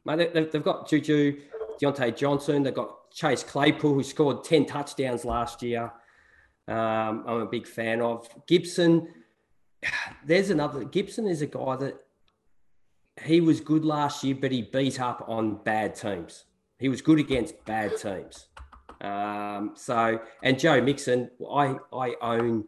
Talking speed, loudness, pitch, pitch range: 150 wpm, -27 LUFS, 135 Hz, 115-155 Hz